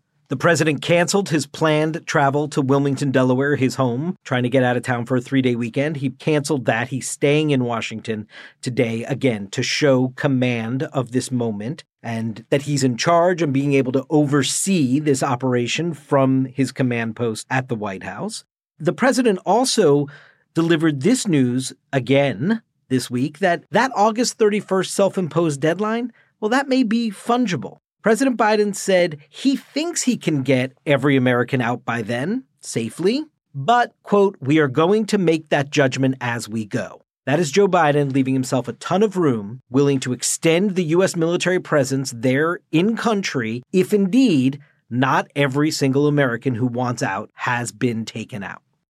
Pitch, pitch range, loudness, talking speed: 145 Hz, 130-175 Hz, -20 LUFS, 165 wpm